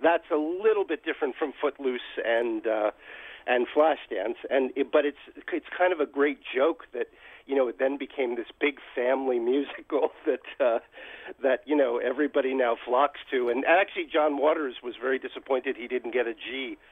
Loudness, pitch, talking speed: -27 LUFS, 145 Hz, 180 wpm